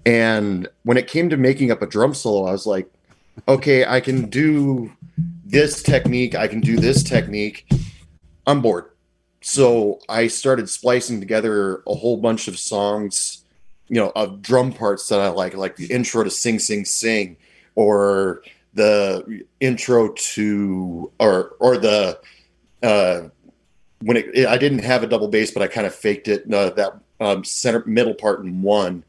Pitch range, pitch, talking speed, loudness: 100-130 Hz, 110 Hz, 165 wpm, -19 LUFS